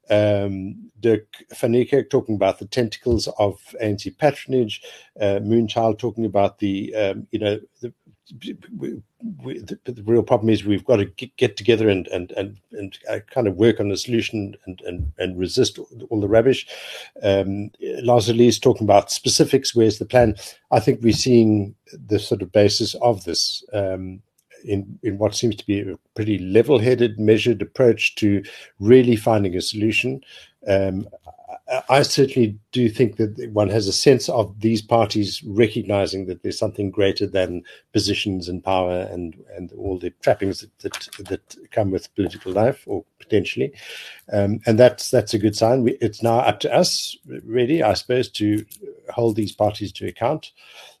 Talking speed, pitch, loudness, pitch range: 170 wpm, 110 Hz, -20 LUFS, 100-120 Hz